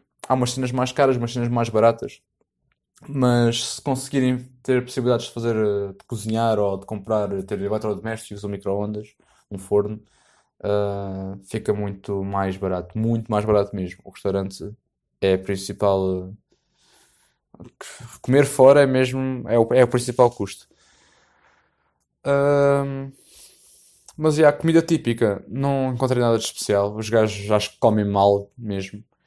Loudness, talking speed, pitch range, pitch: -21 LUFS, 150 wpm, 100-125 Hz, 110 Hz